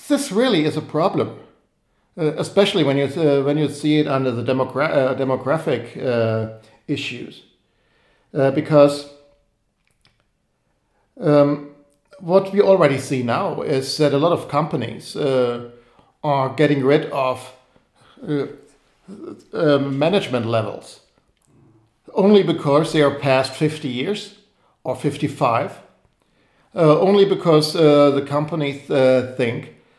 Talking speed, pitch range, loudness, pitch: 120 wpm, 130-155 Hz, -19 LUFS, 145 Hz